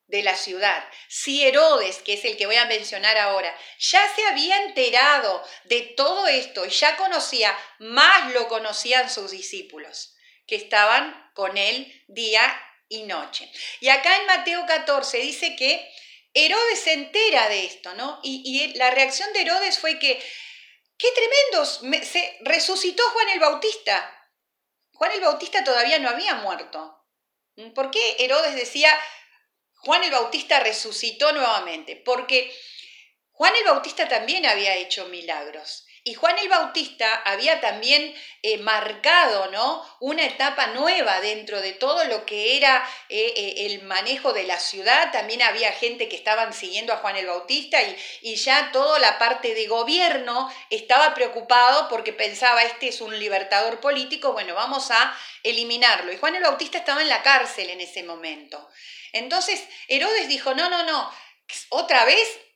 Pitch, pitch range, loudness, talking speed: 265 Hz, 220-335 Hz, -20 LUFS, 155 wpm